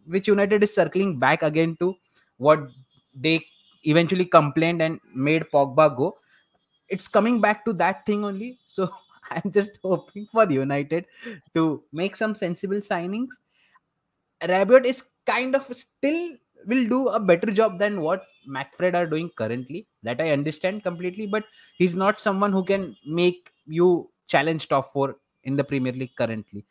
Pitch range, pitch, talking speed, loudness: 155-210 Hz, 180 Hz, 155 wpm, -23 LUFS